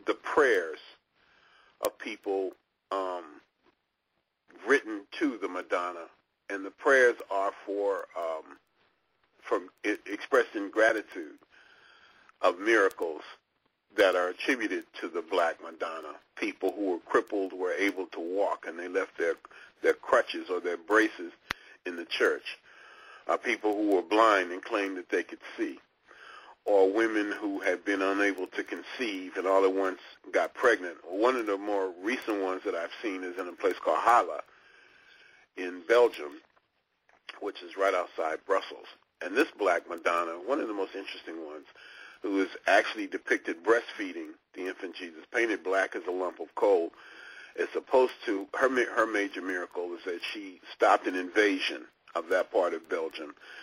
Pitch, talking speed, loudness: 355 Hz, 155 wpm, -29 LUFS